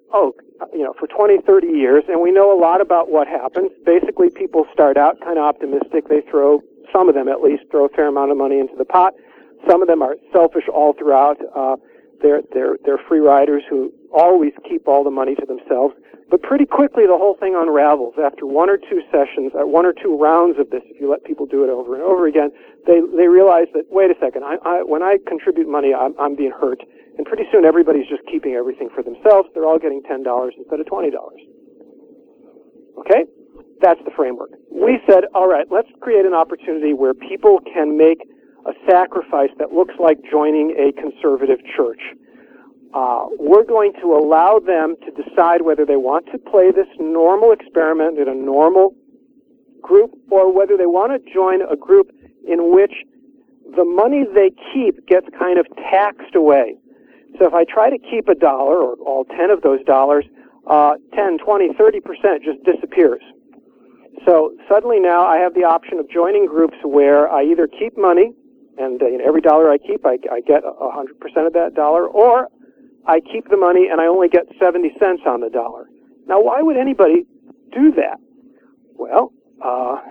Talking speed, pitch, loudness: 195 wpm, 180 Hz, -15 LUFS